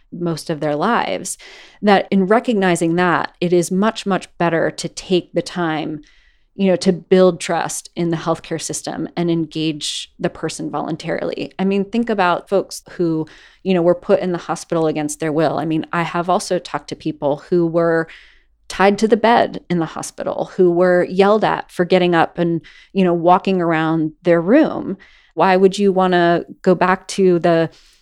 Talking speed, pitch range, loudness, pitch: 185 wpm, 165-185 Hz, -17 LUFS, 175 Hz